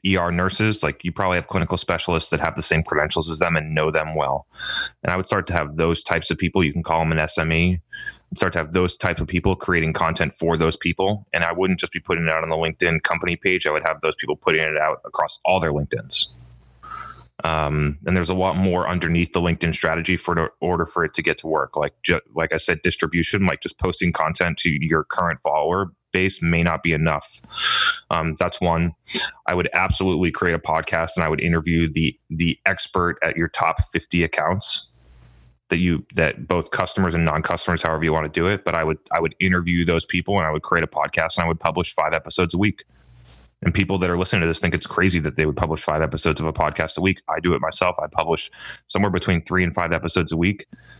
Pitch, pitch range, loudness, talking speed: 85 Hz, 80-90 Hz, -21 LUFS, 235 wpm